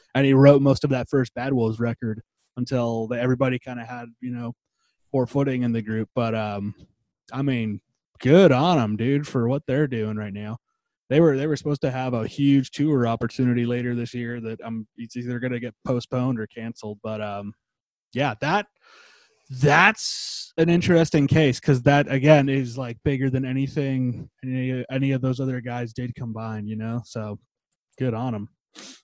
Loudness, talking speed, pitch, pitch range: -23 LUFS, 190 wpm, 125 Hz, 115-135 Hz